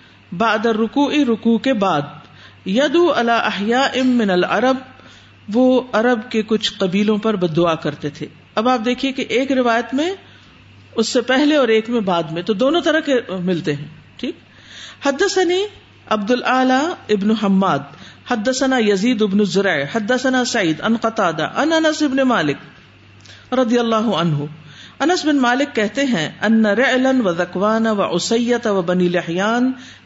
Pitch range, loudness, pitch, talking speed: 190-260 Hz, -17 LUFS, 230 Hz, 145 wpm